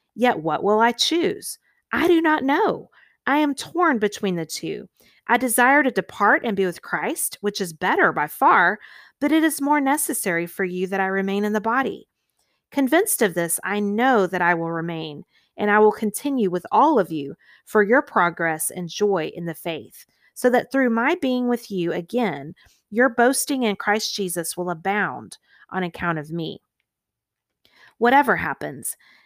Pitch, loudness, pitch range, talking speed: 210 Hz, -21 LUFS, 180-260 Hz, 180 wpm